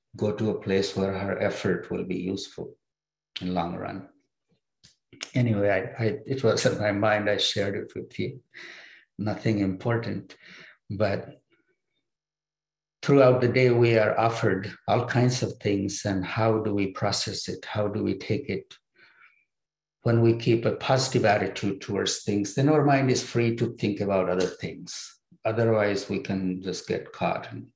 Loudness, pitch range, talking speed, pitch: -26 LUFS, 100-115 Hz, 165 wpm, 105 Hz